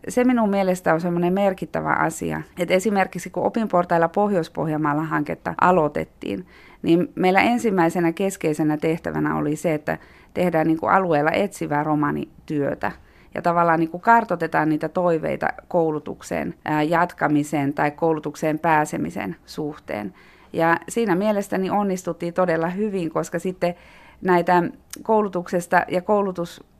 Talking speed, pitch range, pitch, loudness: 120 wpm, 155-185 Hz, 170 Hz, -22 LUFS